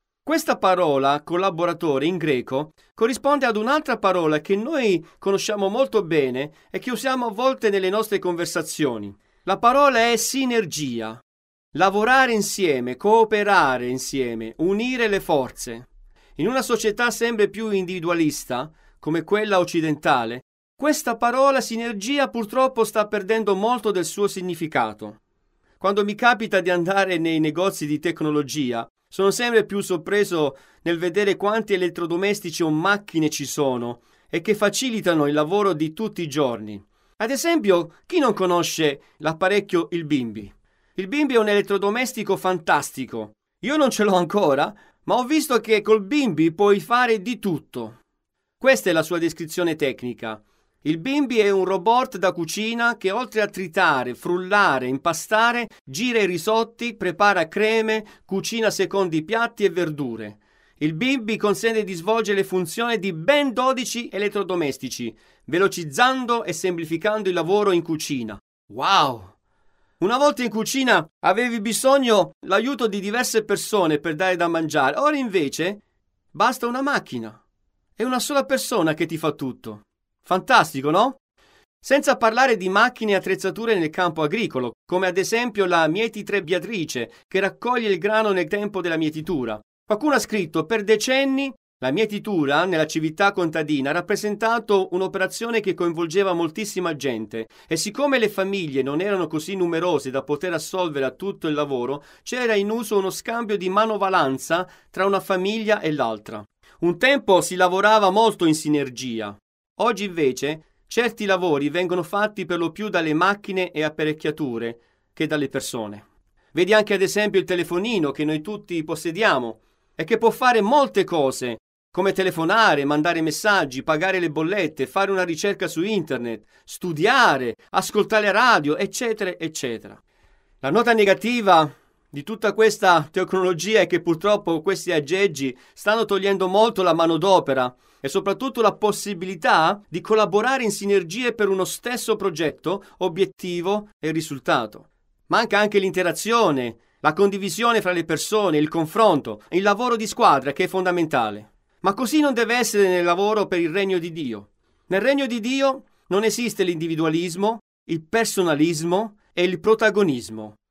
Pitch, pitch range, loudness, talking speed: 190 Hz, 160-220 Hz, -21 LUFS, 145 wpm